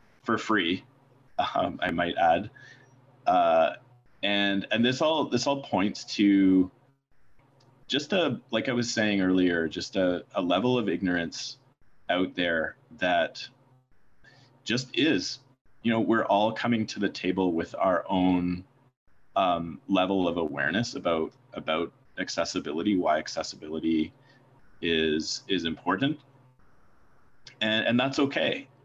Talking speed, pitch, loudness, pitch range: 125 wpm, 110 Hz, -27 LUFS, 90-135 Hz